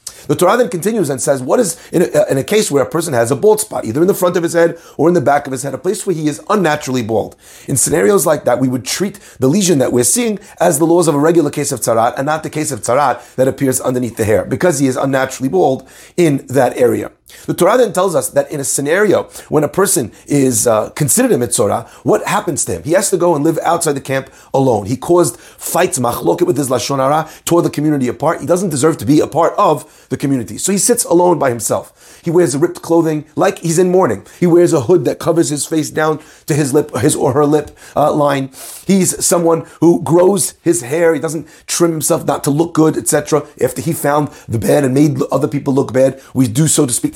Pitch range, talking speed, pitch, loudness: 135-170 Hz, 250 wpm, 155 Hz, -14 LUFS